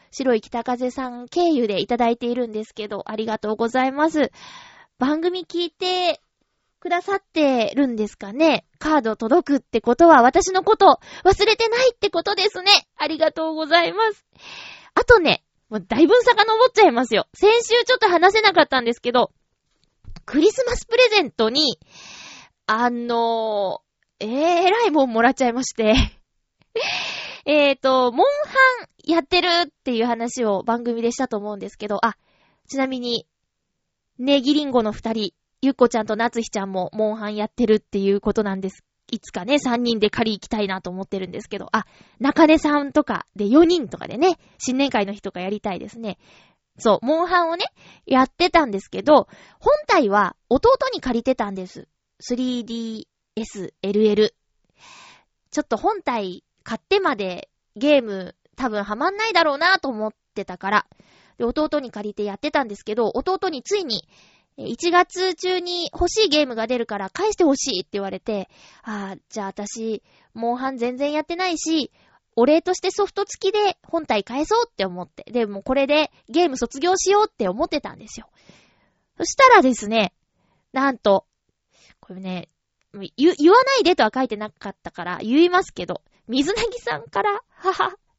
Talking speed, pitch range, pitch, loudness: 335 characters per minute, 215-345 Hz, 260 Hz, -20 LUFS